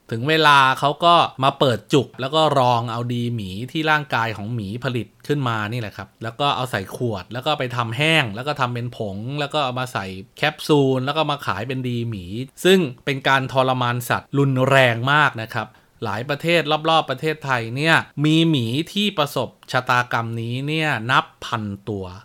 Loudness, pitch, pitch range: -20 LUFS, 130 Hz, 115-150 Hz